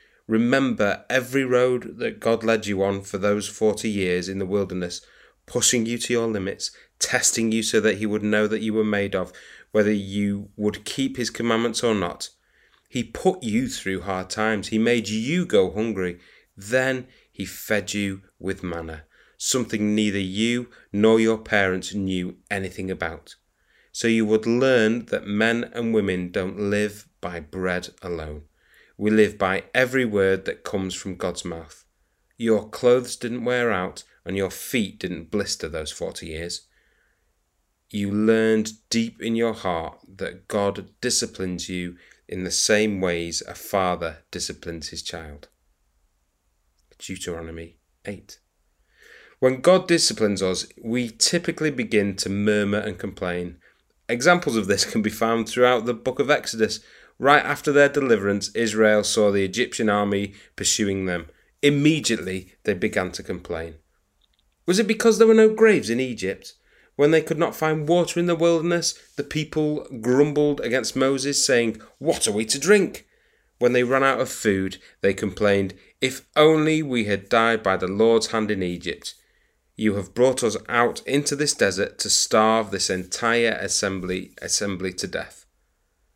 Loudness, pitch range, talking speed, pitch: -22 LUFS, 95-120 Hz, 155 wpm, 105 Hz